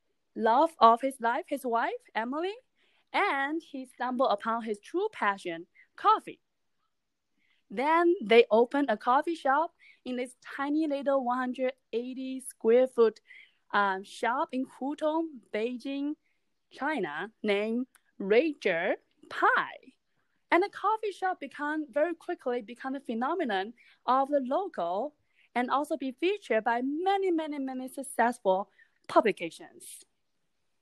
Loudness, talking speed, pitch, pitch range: -29 LUFS, 115 wpm, 270 Hz, 235-325 Hz